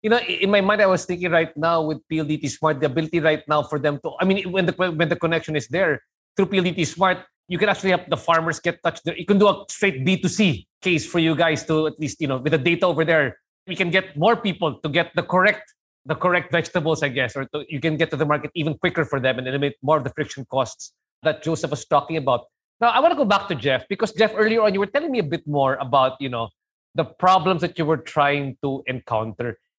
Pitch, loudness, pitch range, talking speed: 165 Hz, -21 LUFS, 150-185 Hz, 260 wpm